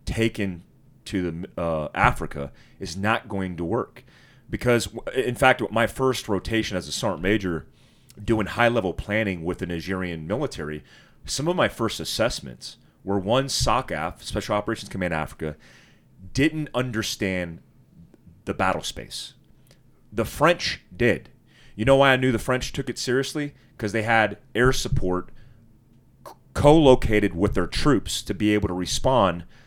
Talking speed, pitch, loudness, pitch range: 150 wpm, 105 Hz, -24 LUFS, 90-125 Hz